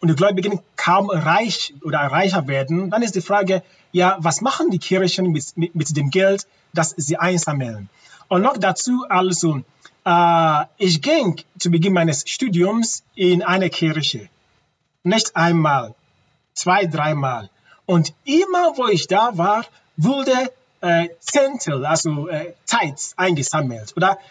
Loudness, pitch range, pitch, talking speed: -19 LUFS, 160-195 Hz, 175 Hz, 140 wpm